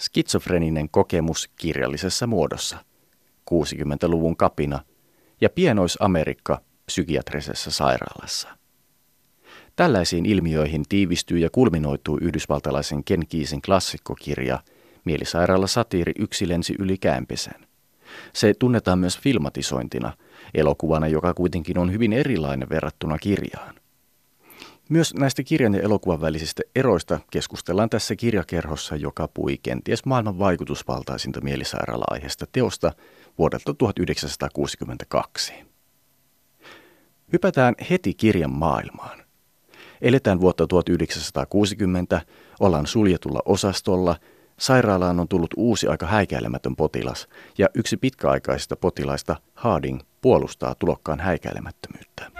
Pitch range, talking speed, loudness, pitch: 75-100 Hz, 90 wpm, -23 LUFS, 85 Hz